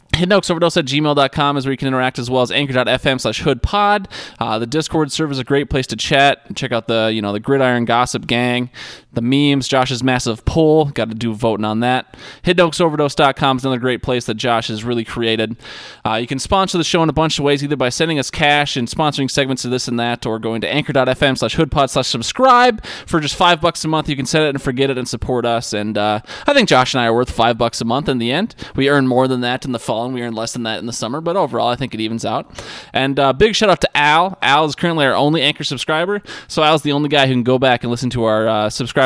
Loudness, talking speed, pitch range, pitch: -16 LUFS, 265 wpm, 120-150 Hz, 130 Hz